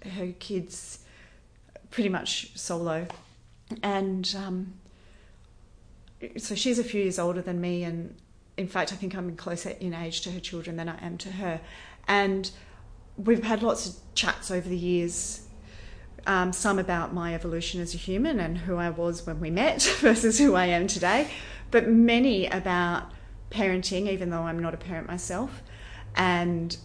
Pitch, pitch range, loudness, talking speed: 180 Hz, 170-195 Hz, -27 LUFS, 165 wpm